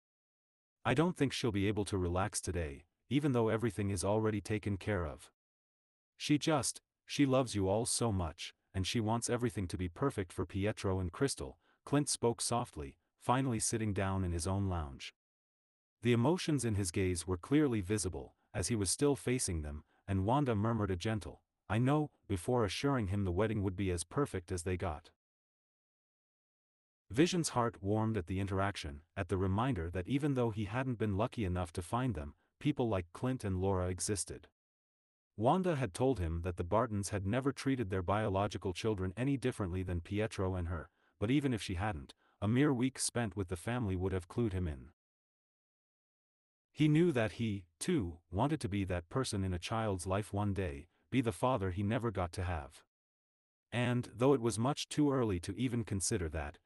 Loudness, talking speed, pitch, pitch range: -35 LUFS, 185 wpm, 105 Hz, 95-120 Hz